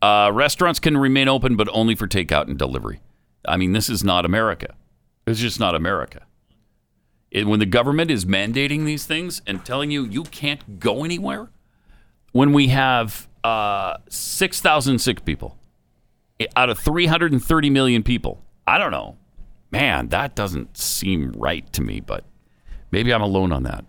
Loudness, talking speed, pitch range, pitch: -20 LUFS, 160 wpm, 105-145 Hz, 120 Hz